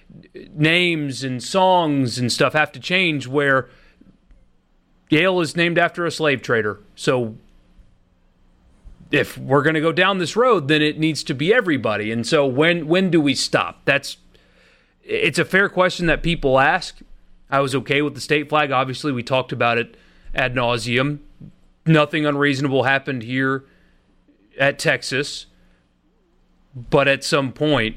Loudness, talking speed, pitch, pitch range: -19 LUFS, 150 wpm, 145 Hz, 125-160 Hz